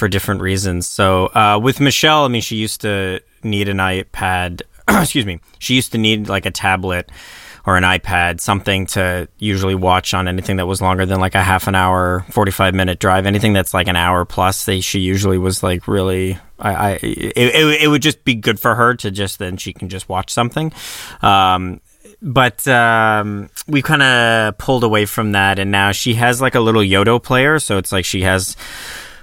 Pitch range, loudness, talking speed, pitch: 95-115 Hz, -15 LUFS, 205 wpm, 100 Hz